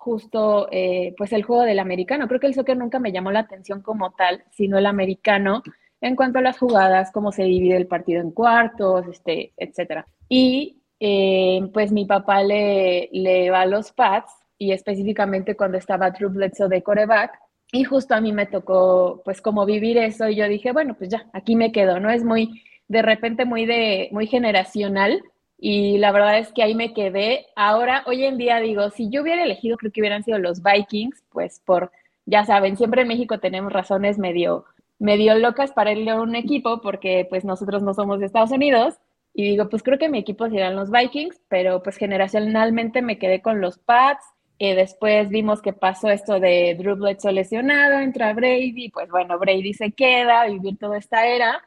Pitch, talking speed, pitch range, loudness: 210 Hz, 195 wpm, 195-230 Hz, -20 LUFS